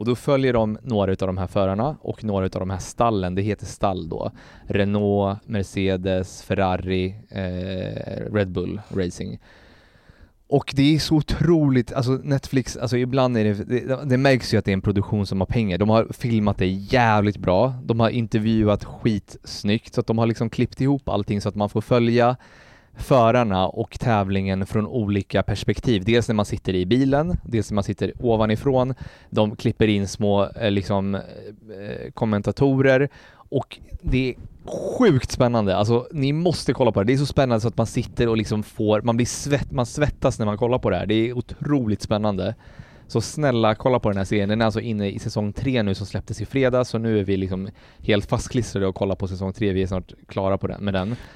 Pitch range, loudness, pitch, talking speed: 100-125 Hz, -22 LUFS, 110 Hz, 200 wpm